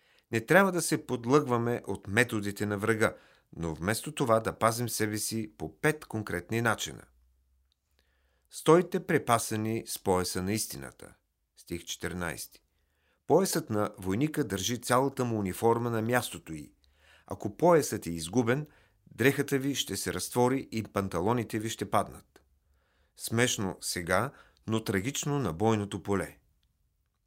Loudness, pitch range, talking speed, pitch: -30 LUFS, 85-120 Hz, 130 wpm, 105 Hz